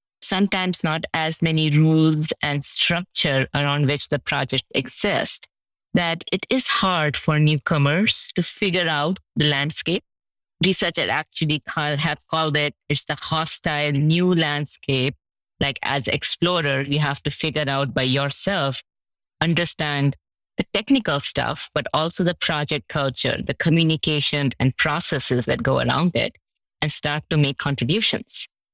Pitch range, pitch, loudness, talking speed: 145-170 Hz, 150 Hz, -21 LUFS, 140 wpm